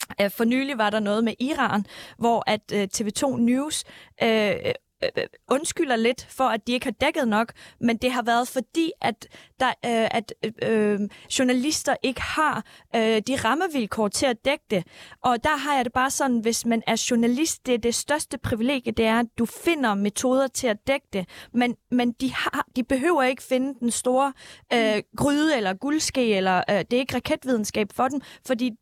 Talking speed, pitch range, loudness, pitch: 190 wpm, 225-275 Hz, -24 LUFS, 250 Hz